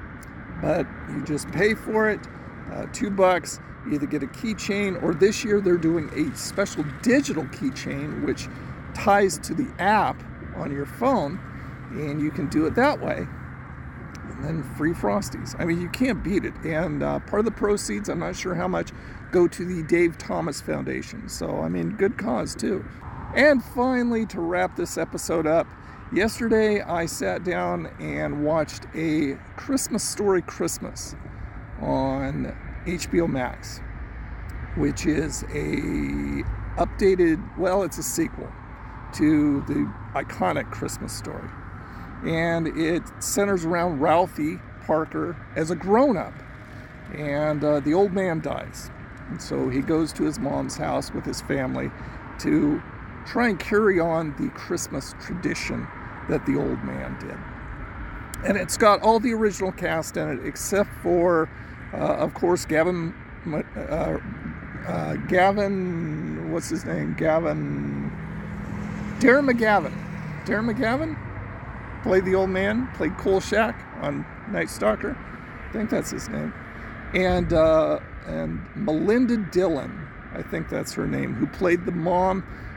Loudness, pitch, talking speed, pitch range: -25 LUFS, 170 Hz, 145 wpm, 145-200 Hz